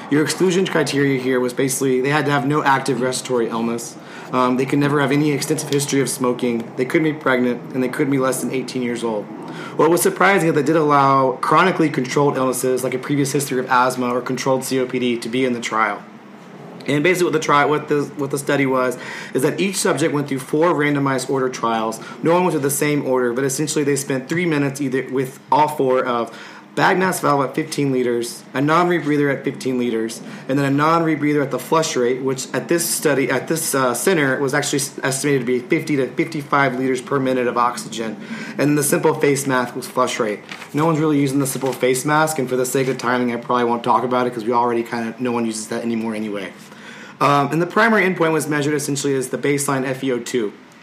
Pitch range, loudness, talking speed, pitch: 125-150 Hz, -19 LUFS, 230 wpm, 135 Hz